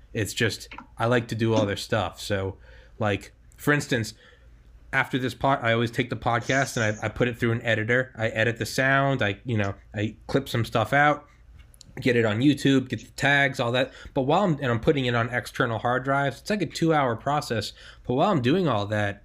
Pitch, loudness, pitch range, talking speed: 120 Hz, -25 LUFS, 110-135 Hz, 230 wpm